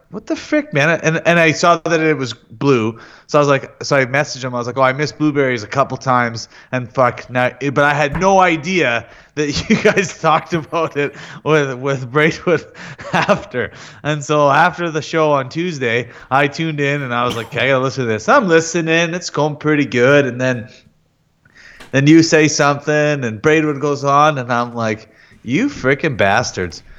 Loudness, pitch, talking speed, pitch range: -16 LUFS, 145 Hz, 200 wpm, 125-155 Hz